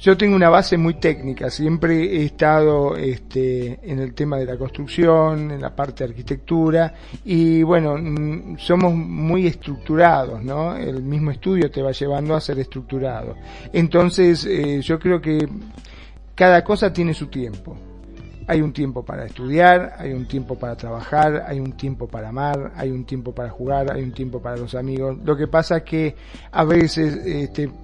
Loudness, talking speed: -19 LUFS, 175 wpm